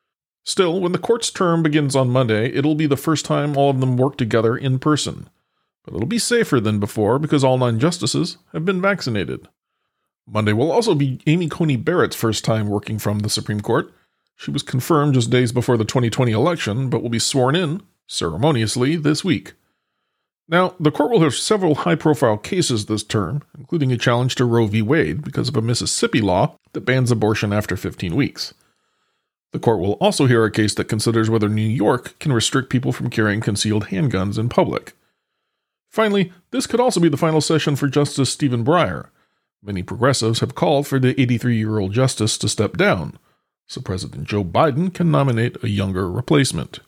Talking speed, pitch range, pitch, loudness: 190 wpm, 110-155 Hz, 130 Hz, -19 LUFS